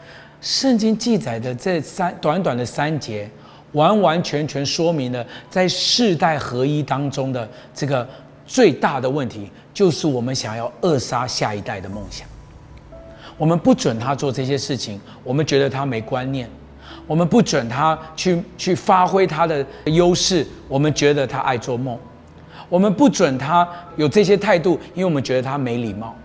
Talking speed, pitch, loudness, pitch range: 245 characters per minute, 145 Hz, -19 LUFS, 125-175 Hz